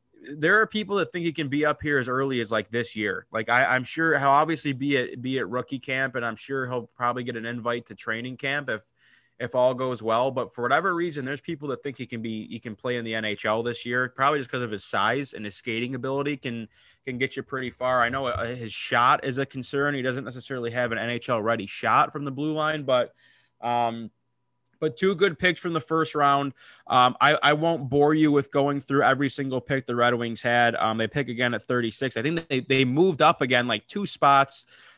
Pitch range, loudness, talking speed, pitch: 120-145 Hz, -25 LUFS, 240 wpm, 130 Hz